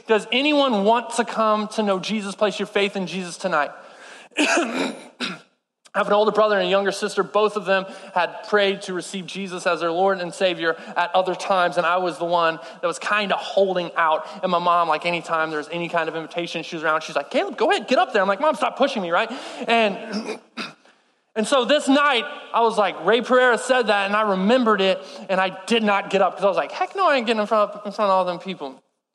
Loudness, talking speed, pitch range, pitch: -21 LUFS, 245 wpm, 180-220 Hz, 195 Hz